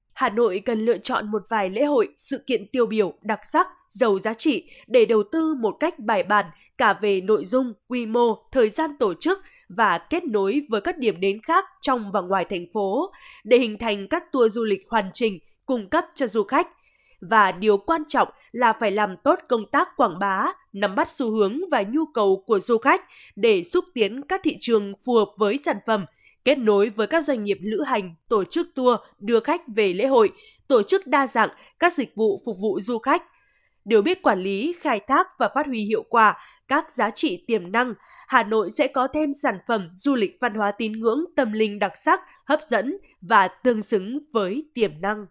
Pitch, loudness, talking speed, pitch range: 245 Hz, -22 LUFS, 215 wpm, 215-320 Hz